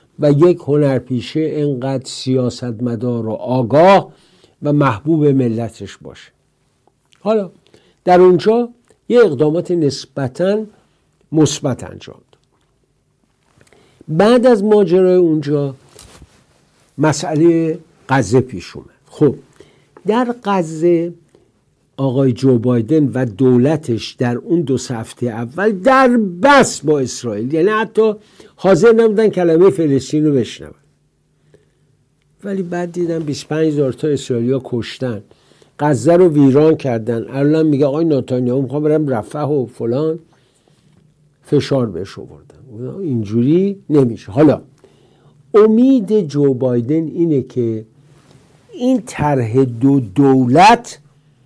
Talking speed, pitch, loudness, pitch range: 105 wpm, 145 Hz, -15 LUFS, 130-170 Hz